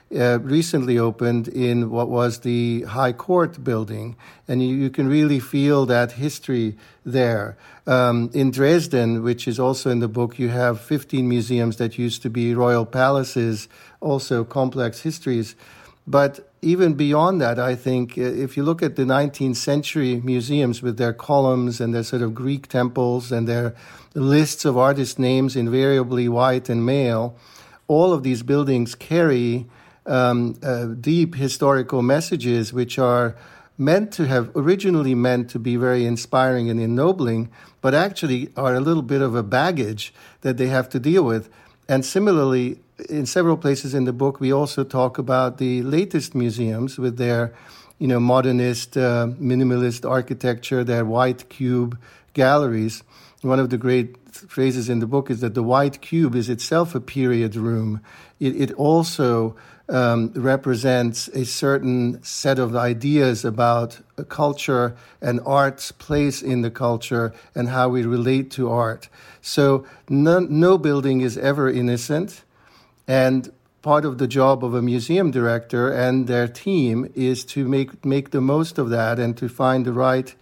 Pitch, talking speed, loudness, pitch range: 130 Hz, 160 wpm, -20 LUFS, 120-140 Hz